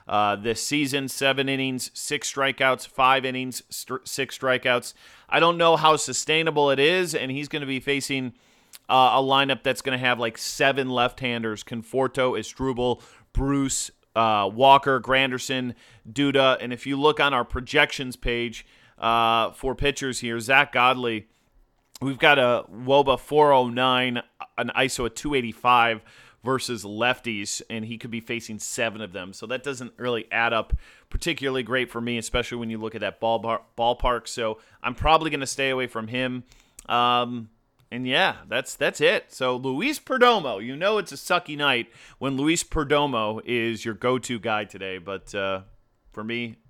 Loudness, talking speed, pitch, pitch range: -23 LUFS, 165 wpm, 125 Hz, 115-135 Hz